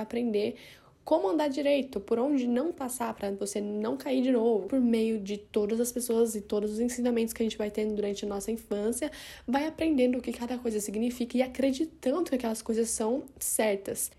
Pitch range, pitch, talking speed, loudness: 215-260 Hz, 235 Hz, 200 wpm, -30 LUFS